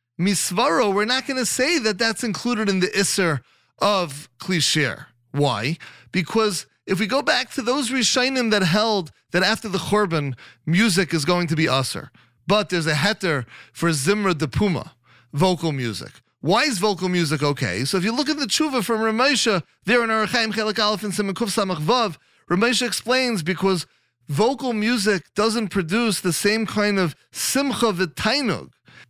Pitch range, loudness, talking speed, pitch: 165-225 Hz, -21 LUFS, 165 wpm, 200 Hz